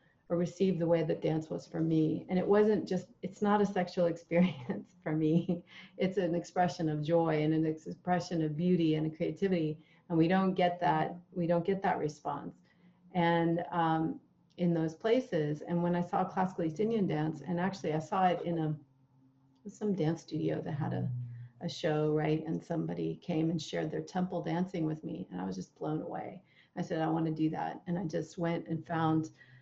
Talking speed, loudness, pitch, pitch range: 205 wpm, -33 LUFS, 170 Hz, 155-180 Hz